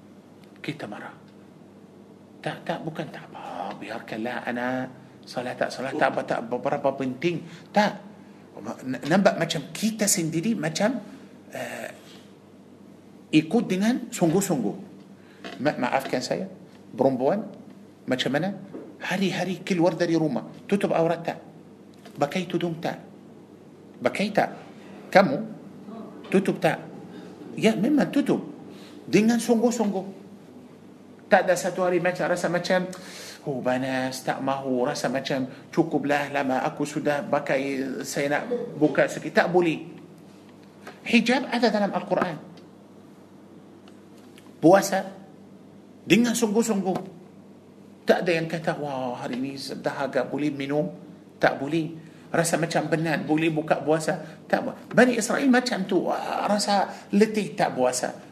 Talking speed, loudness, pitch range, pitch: 120 wpm, -25 LUFS, 150-210 Hz, 180 Hz